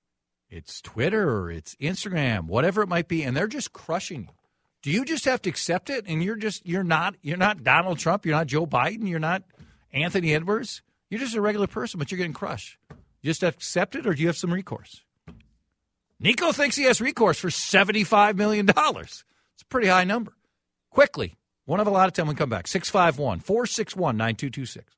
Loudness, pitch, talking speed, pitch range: -24 LUFS, 180 Hz, 195 wpm, 155-210 Hz